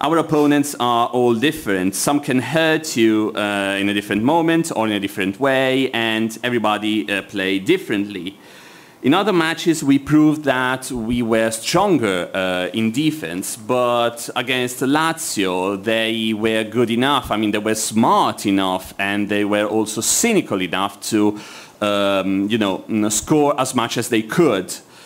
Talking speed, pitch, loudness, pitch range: 155 wpm, 110 Hz, -18 LUFS, 105-130 Hz